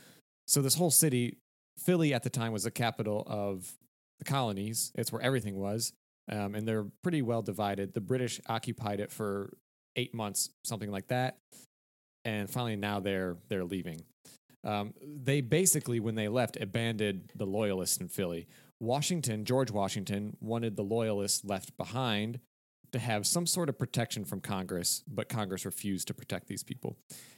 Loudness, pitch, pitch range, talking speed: -33 LUFS, 110 Hz, 100-125 Hz, 160 wpm